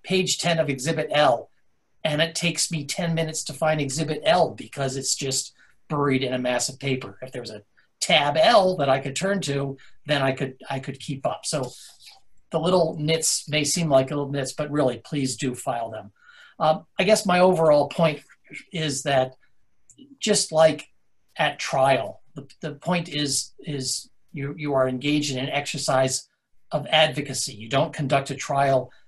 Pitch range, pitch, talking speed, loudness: 135-160 Hz, 145 Hz, 180 wpm, -23 LUFS